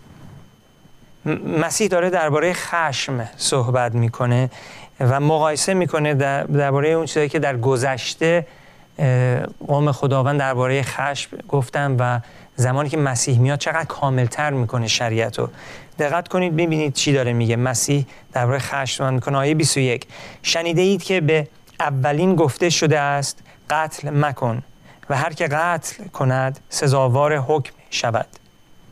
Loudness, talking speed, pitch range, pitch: -20 LUFS, 125 wpm, 130-155 Hz, 140 Hz